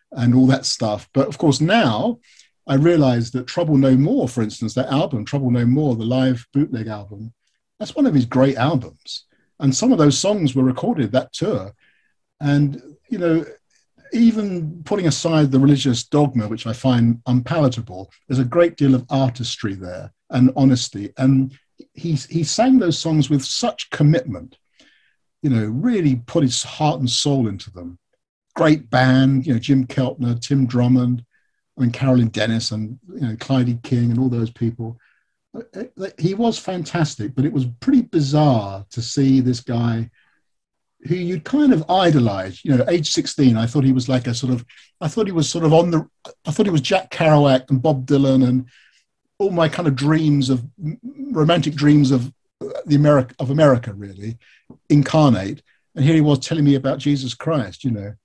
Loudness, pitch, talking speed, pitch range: -18 LUFS, 135 Hz, 180 wpm, 125-155 Hz